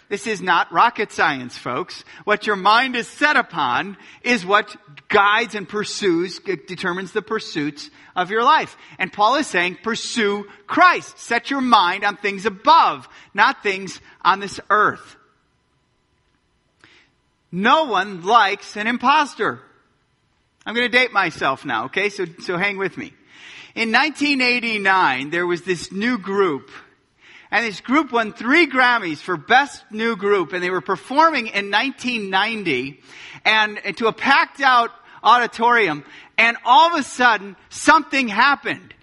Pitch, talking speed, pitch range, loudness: 215 Hz, 145 wpm, 190-250 Hz, -18 LUFS